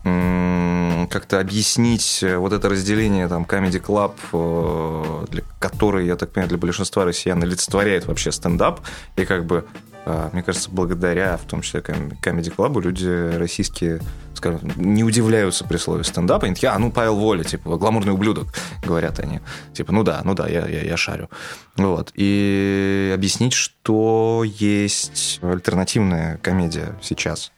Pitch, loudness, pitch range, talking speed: 95 Hz, -20 LUFS, 90-105 Hz, 145 wpm